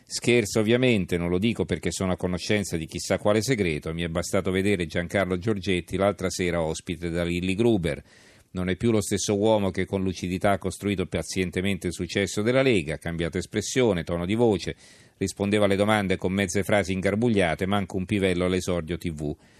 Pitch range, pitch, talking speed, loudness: 90-105 Hz, 95 Hz, 180 wpm, -25 LUFS